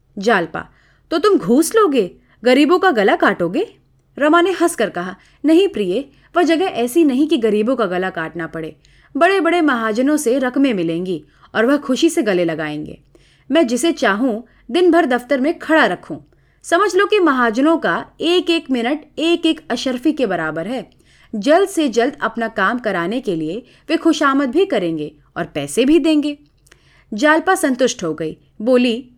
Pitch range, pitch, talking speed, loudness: 210-325 Hz, 260 Hz, 165 wpm, -16 LUFS